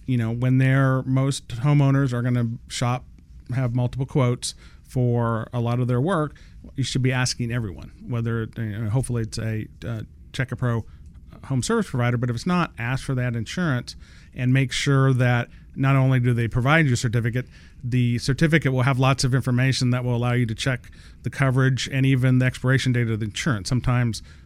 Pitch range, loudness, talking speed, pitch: 115-130 Hz, -23 LUFS, 200 wpm, 125 Hz